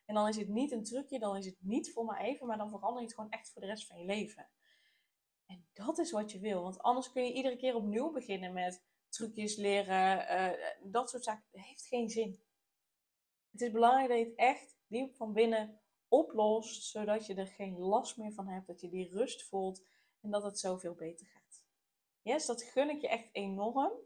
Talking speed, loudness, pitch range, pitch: 220 wpm, -36 LUFS, 195-240 Hz, 215 Hz